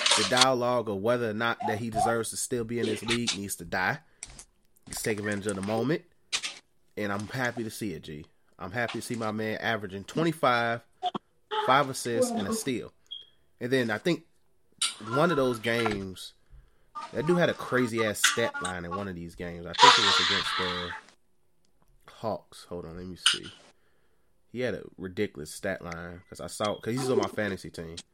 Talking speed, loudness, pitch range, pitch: 195 wpm, -28 LUFS, 90-120 Hz, 110 Hz